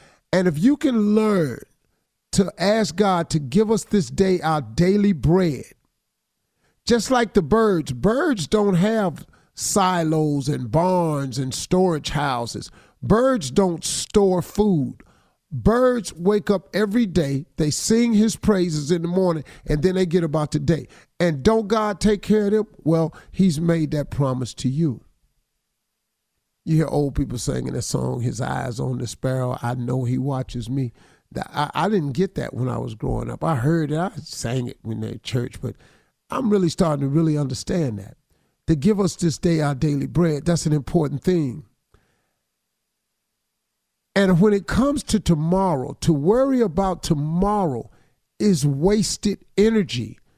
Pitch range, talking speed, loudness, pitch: 140-200 Hz, 160 wpm, -21 LUFS, 165 Hz